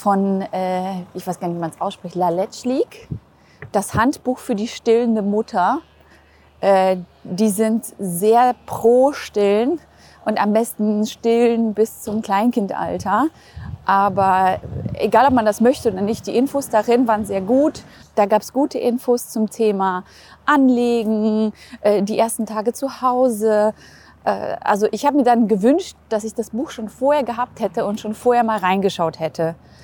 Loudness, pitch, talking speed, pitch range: -19 LUFS, 220 Hz, 150 wpm, 200-245 Hz